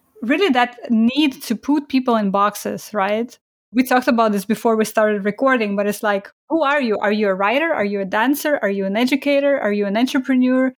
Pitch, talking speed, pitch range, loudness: 230 Hz, 215 wpm, 205-270 Hz, -18 LUFS